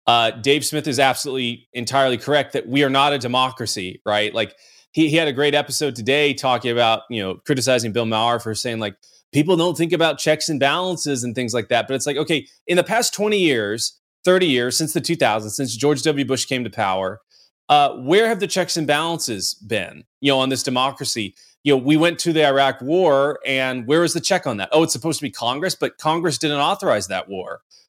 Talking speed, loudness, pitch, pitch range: 225 wpm, -19 LUFS, 140 Hz, 120-155 Hz